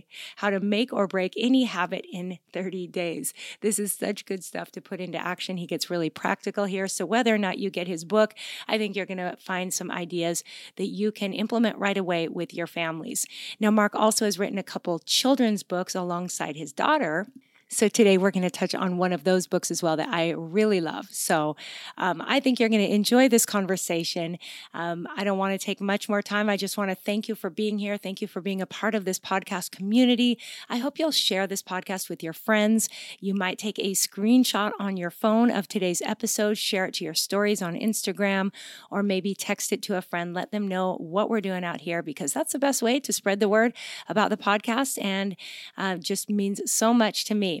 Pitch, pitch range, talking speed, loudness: 200 Hz, 185-215 Hz, 225 wpm, -26 LUFS